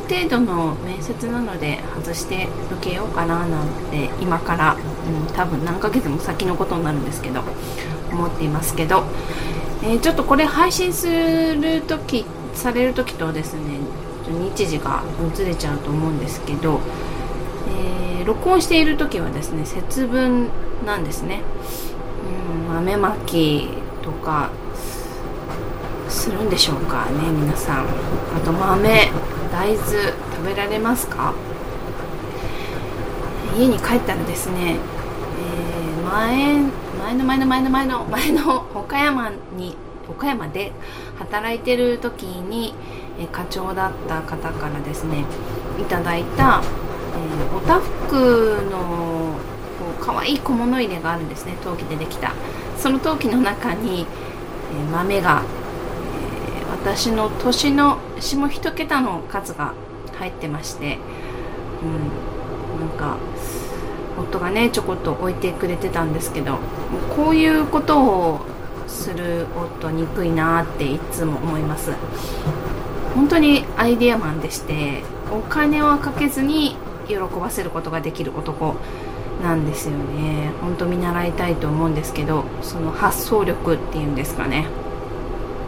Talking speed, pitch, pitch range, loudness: 255 characters per minute, 180 Hz, 160-255 Hz, -21 LUFS